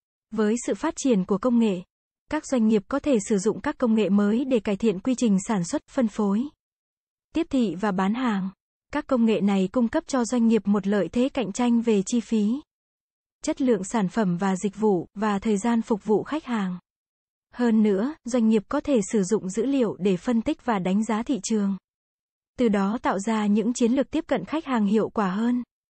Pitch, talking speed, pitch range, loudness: 225 Hz, 220 wpm, 210-255 Hz, -24 LUFS